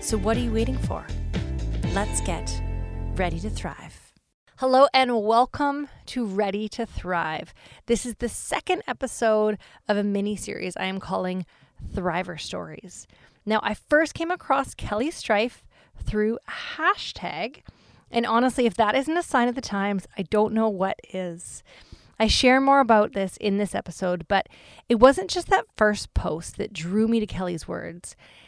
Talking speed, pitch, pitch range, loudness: 160 wpm, 215 Hz, 190-250 Hz, -25 LUFS